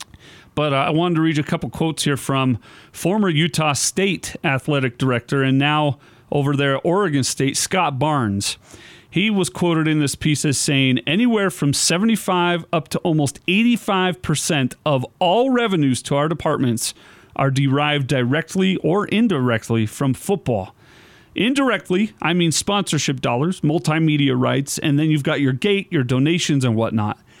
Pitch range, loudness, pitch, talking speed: 135-175 Hz, -19 LUFS, 150 Hz, 155 wpm